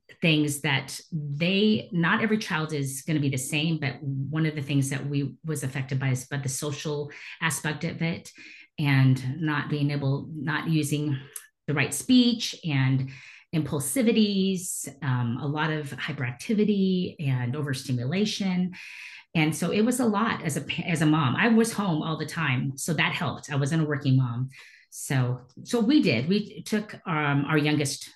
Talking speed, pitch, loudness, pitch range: 175 wpm, 150 Hz, -26 LUFS, 140-175 Hz